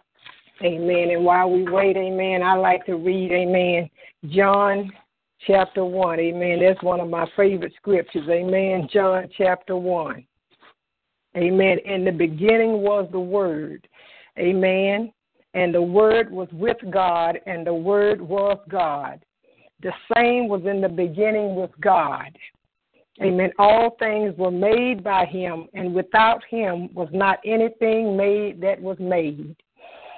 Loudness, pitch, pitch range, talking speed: -21 LUFS, 190 Hz, 180-205 Hz, 135 wpm